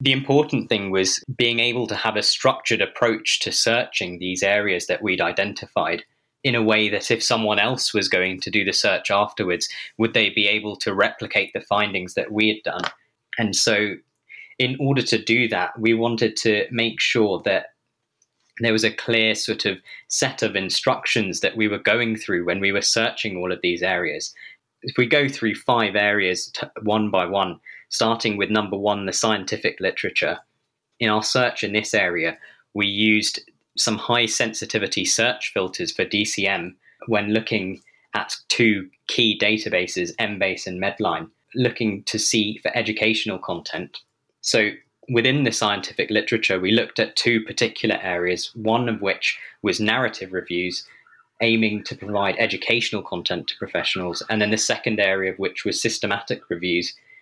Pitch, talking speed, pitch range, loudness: 110 Hz, 170 wpm, 100-115 Hz, -21 LUFS